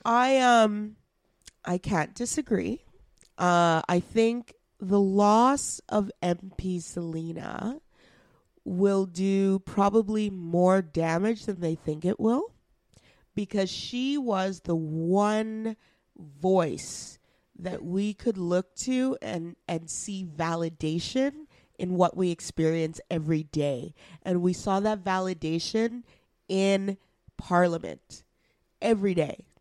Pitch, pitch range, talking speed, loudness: 190 Hz, 170-215 Hz, 105 wpm, -27 LUFS